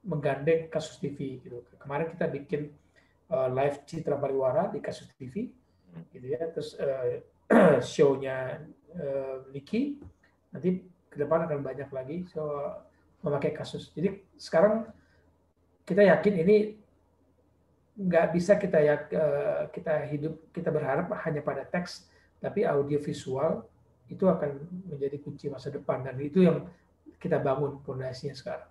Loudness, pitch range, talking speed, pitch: -29 LUFS, 135-175 Hz, 125 wpm, 150 Hz